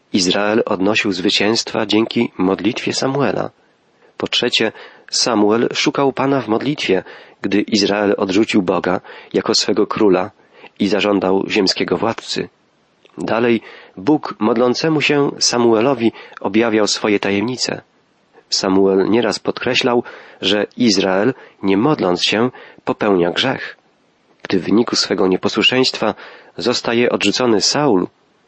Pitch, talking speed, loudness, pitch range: 110 Hz, 105 wpm, -16 LUFS, 100-125 Hz